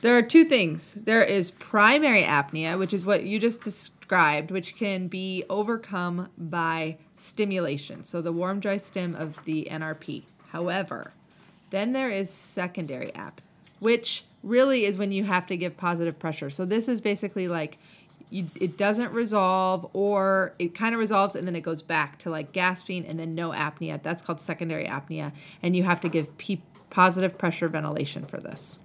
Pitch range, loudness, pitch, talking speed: 165-200 Hz, -26 LUFS, 180 Hz, 175 wpm